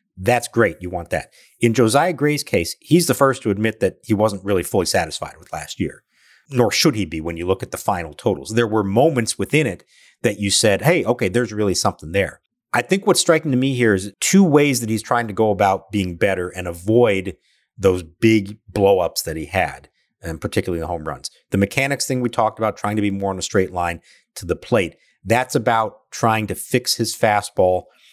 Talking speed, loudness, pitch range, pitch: 220 wpm, -19 LUFS, 95-125 Hz, 110 Hz